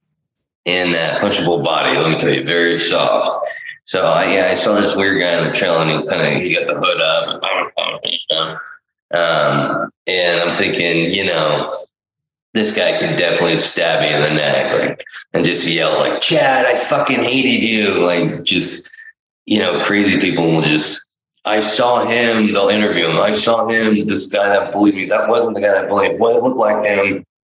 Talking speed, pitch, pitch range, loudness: 190 wpm, 105 Hz, 85-115 Hz, -15 LUFS